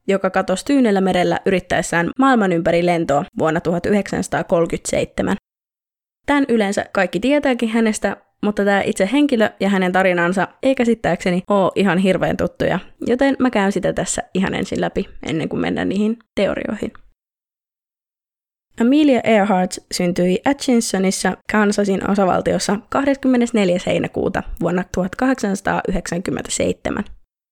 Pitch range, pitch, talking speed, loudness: 185-235 Hz, 200 Hz, 110 wpm, -18 LUFS